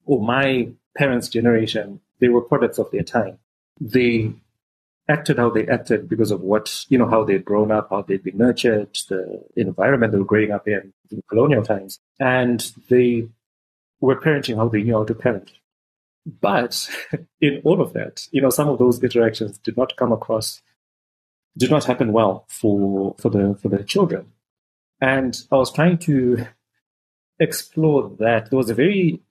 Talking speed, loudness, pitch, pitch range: 170 wpm, -20 LUFS, 115 Hz, 105-130 Hz